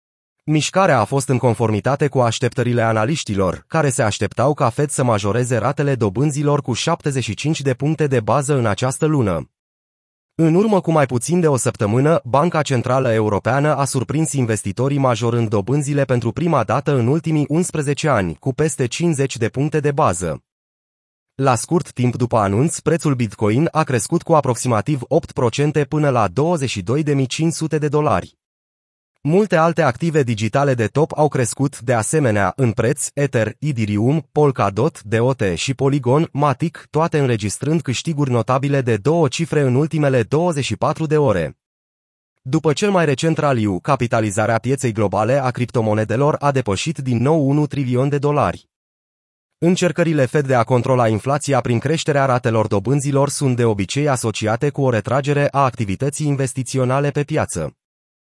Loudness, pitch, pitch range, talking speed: -18 LUFS, 135 Hz, 120-150 Hz, 150 wpm